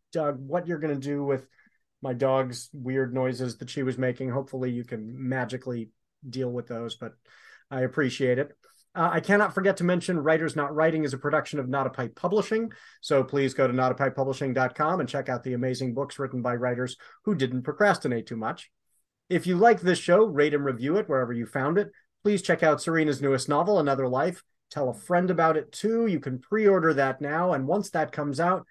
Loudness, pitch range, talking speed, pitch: -26 LUFS, 130-165 Hz, 210 wpm, 140 Hz